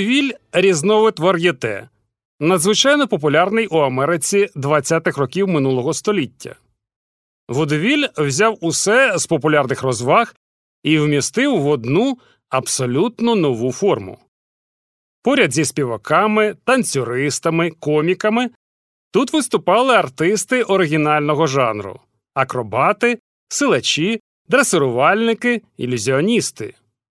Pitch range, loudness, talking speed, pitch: 135-215 Hz, -17 LUFS, 80 wpm, 165 Hz